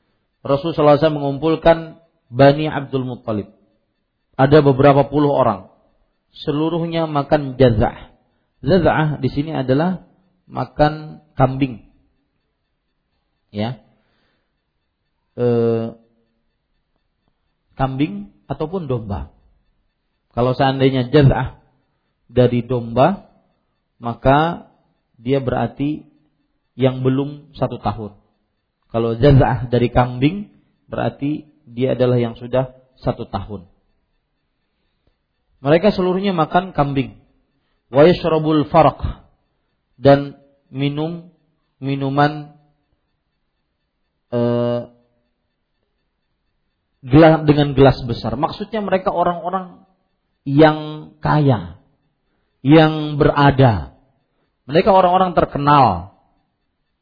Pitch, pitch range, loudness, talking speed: 135 Hz, 120-155 Hz, -17 LUFS, 70 wpm